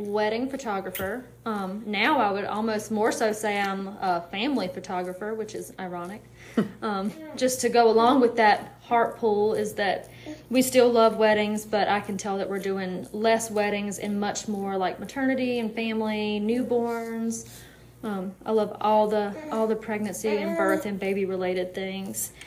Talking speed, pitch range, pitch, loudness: 170 wpm, 195-225 Hz, 210 Hz, -26 LUFS